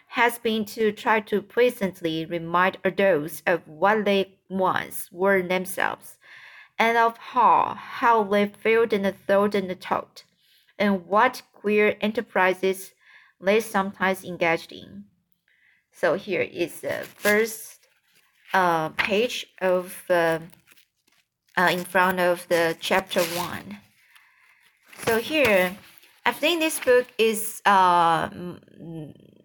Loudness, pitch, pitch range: -23 LUFS, 195 Hz, 180-225 Hz